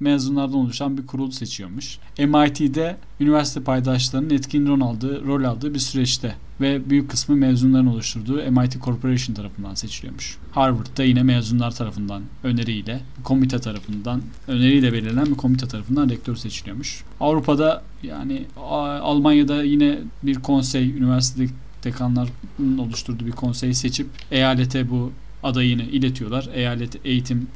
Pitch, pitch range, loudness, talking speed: 130 Hz, 120-140 Hz, -21 LUFS, 120 wpm